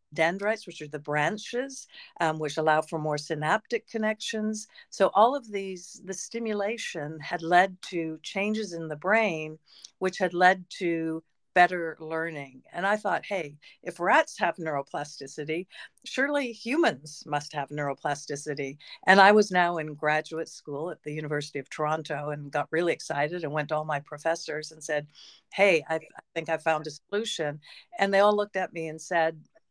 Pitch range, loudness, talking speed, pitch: 150-195 Hz, -28 LUFS, 170 wpm, 165 Hz